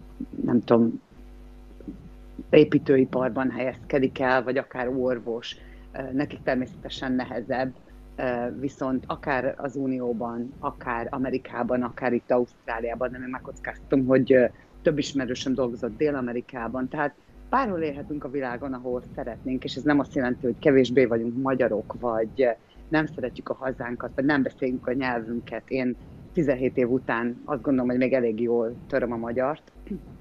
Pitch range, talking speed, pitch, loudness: 120-135 Hz, 130 wpm, 130 Hz, -26 LUFS